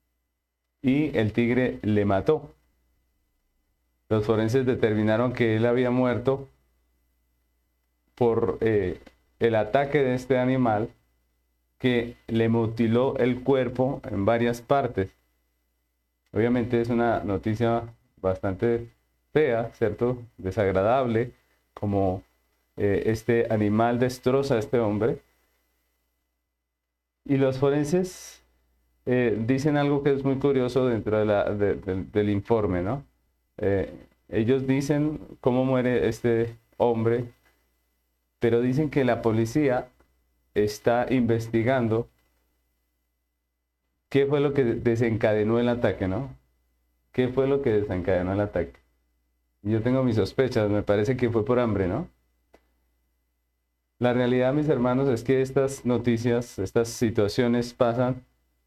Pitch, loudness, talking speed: 110 Hz, -25 LUFS, 115 wpm